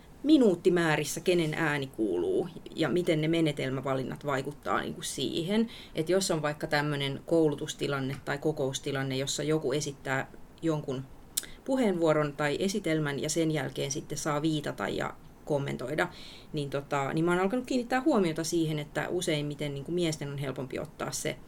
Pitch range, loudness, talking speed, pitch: 145-175 Hz, -30 LUFS, 145 wpm, 155 Hz